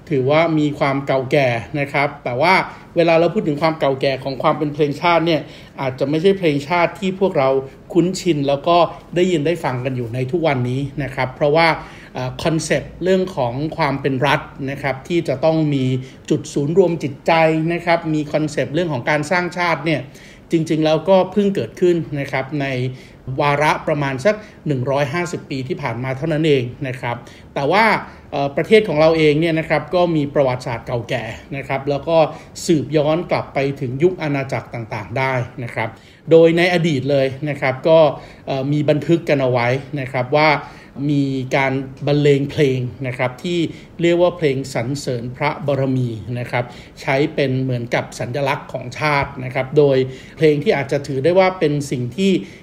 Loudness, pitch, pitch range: -18 LUFS, 145 Hz, 135-165 Hz